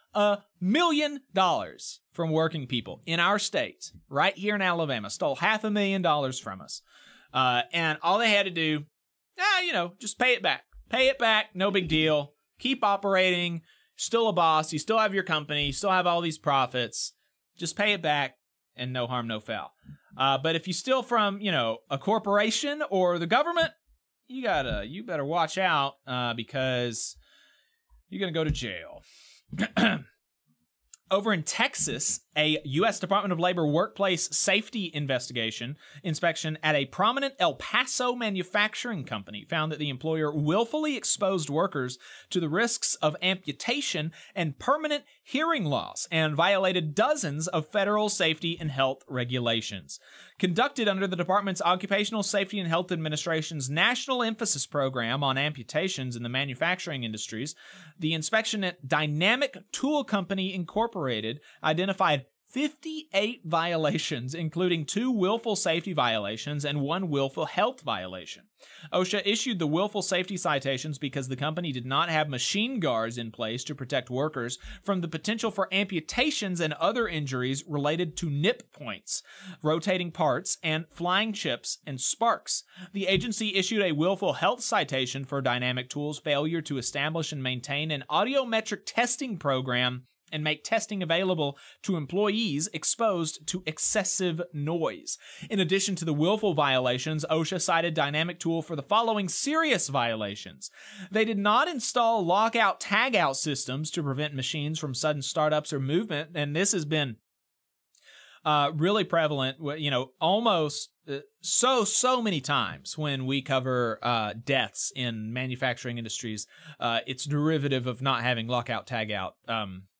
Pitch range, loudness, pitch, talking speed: 140-200 Hz, -27 LUFS, 165 Hz, 150 wpm